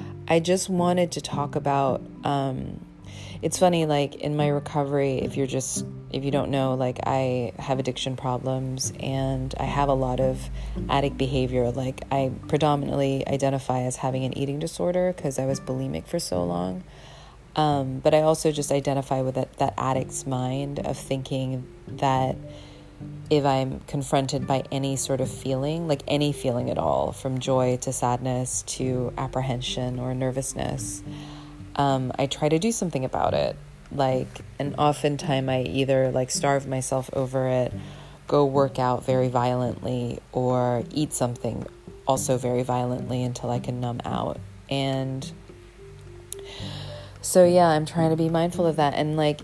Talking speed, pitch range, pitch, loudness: 160 wpm, 125-145 Hz, 135 Hz, -25 LUFS